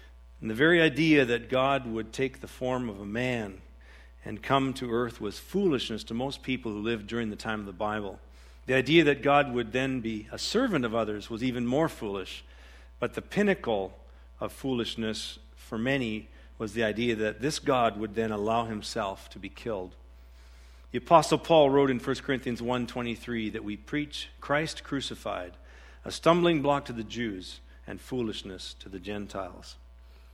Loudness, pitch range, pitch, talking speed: -29 LUFS, 95-130 Hz, 115 Hz, 175 wpm